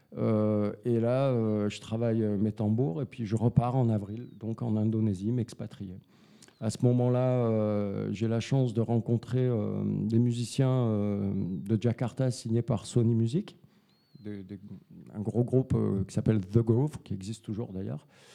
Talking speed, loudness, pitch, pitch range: 165 wpm, -29 LUFS, 115 Hz, 105-125 Hz